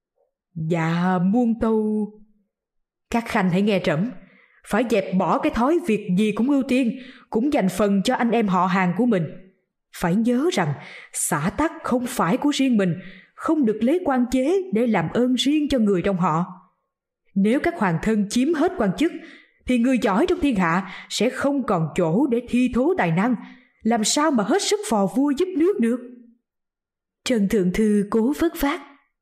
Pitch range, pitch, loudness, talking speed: 195-270 Hz, 235 Hz, -21 LUFS, 185 wpm